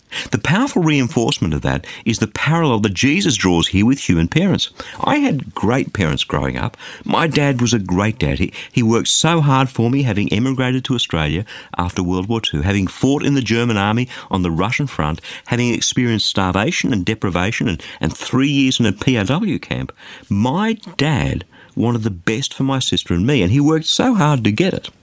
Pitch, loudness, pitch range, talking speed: 120 Hz, -17 LUFS, 100-135 Hz, 195 wpm